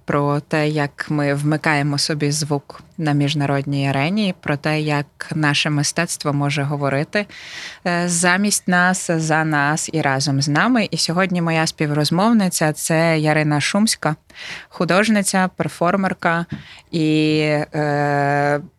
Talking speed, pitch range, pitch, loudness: 110 wpm, 145-175 Hz, 155 Hz, -18 LUFS